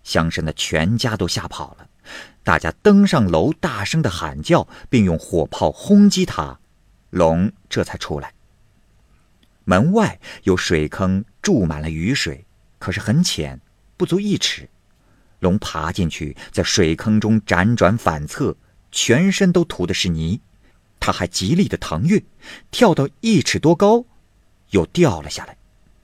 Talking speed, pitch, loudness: 200 characters per minute, 100 Hz, -18 LUFS